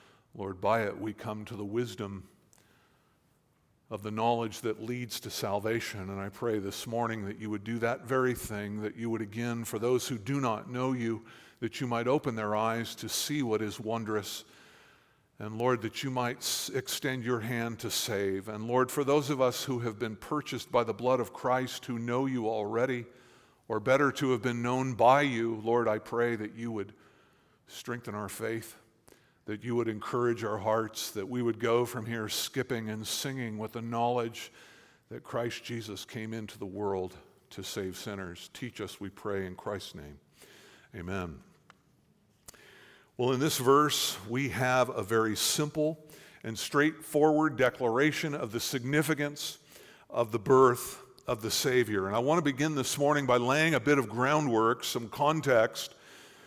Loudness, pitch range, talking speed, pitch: -31 LUFS, 110-130 Hz, 175 wpm, 115 Hz